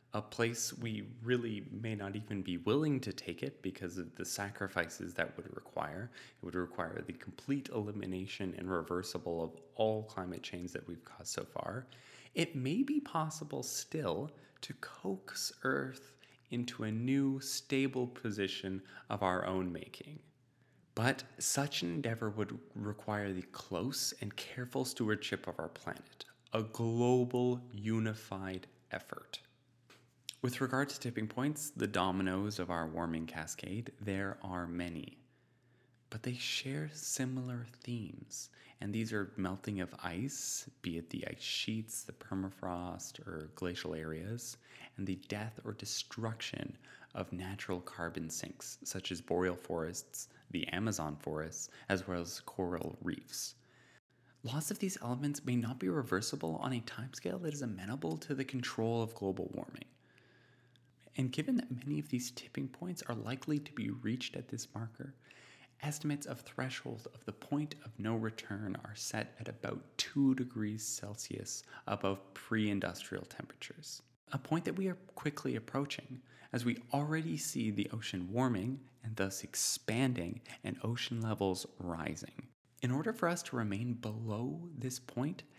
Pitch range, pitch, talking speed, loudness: 95-130 Hz, 115 Hz, 150 wpm, -39 LUFS